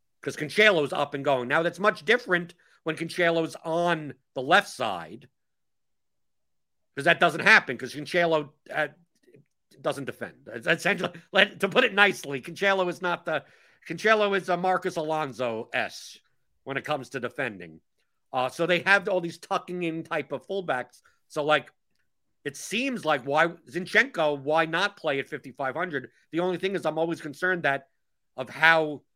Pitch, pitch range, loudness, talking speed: 165 Hz, 145-180 Hz, -25 LUFS, 165 wpm